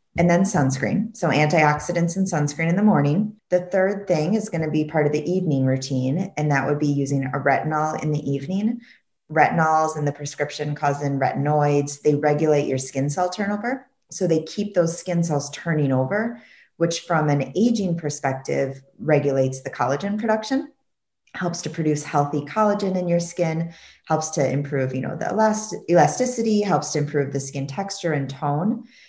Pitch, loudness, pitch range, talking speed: 155 Hz, -22 LUFS, 145-190 Hz, 175 wpm